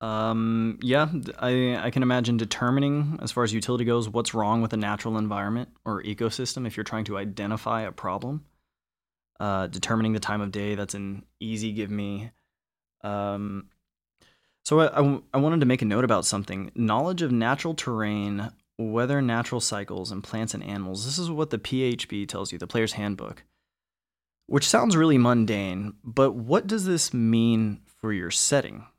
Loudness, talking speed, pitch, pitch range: -26 LUFS, 175 wpm, 110 Hz, 100-125 Hz